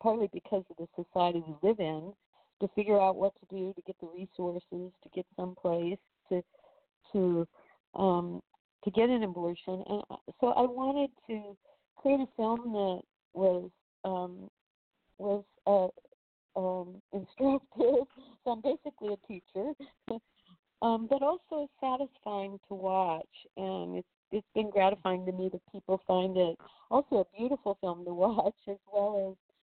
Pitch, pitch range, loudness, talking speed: 200 Hz, 185-230 Hz, -33 LUFS, 150 wpm